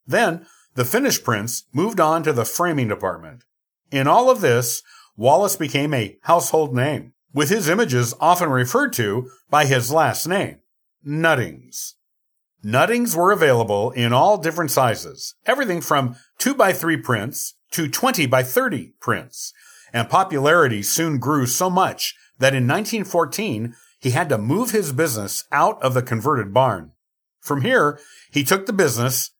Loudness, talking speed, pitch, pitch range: -19 LUFS, 145 wpm, 145 Hz, 125-170 Hz